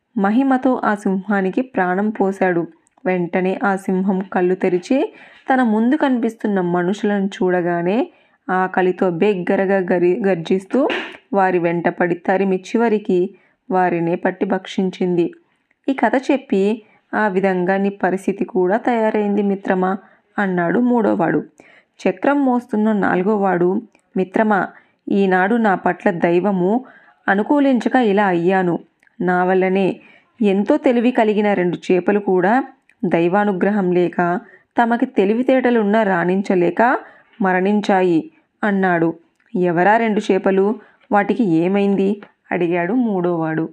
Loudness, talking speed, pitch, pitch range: -18 LUFS, 100 wpm, 195 Hz, 185-225 Hz